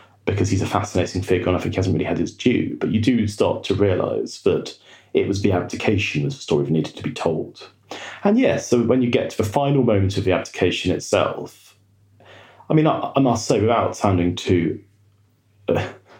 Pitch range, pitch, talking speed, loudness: 90-110 Hz, 100 Hz, 210 wpm, -21 LUFS